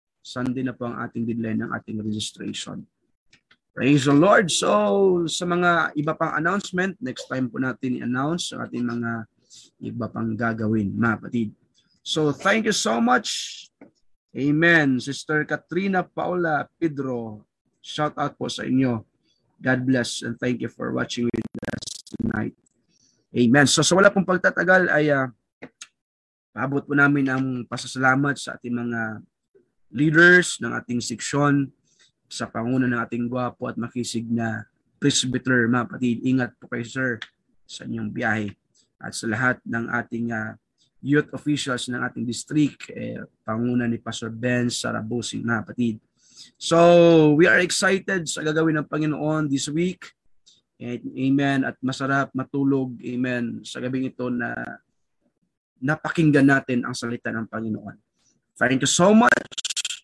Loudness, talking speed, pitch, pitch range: -22 LUFS, 145 wpm, 130 Hz, 120-150 Hz